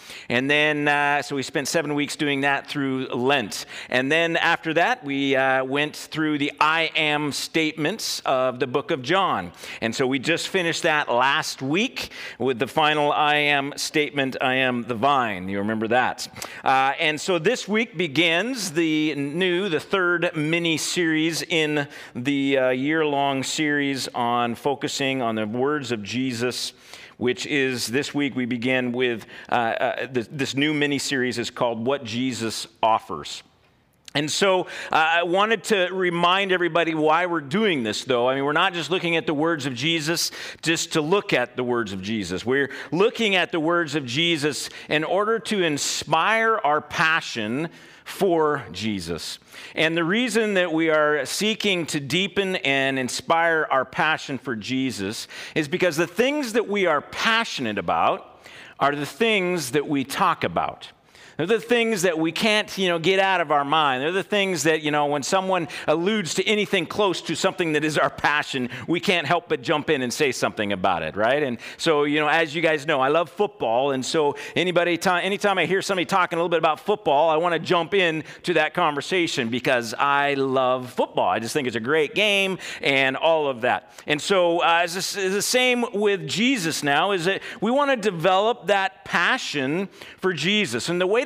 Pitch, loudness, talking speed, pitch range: 155 Hz, -22 LUFS, 185 wpm, 135-180 Hz